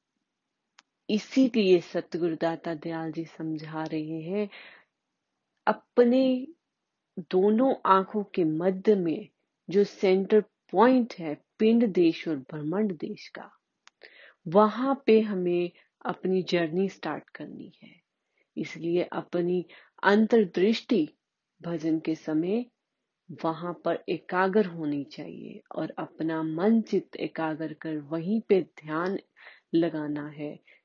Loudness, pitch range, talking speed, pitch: -27 LUFS, 160-215 Hz, 90 wpm, 180 Hz